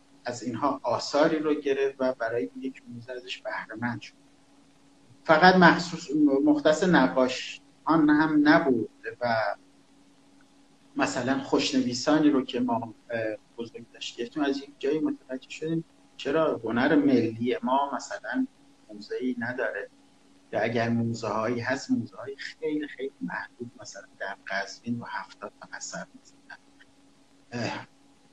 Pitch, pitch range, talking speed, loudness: 140 Hz, 125-160 Hz, 120 wpm, -26 LUFS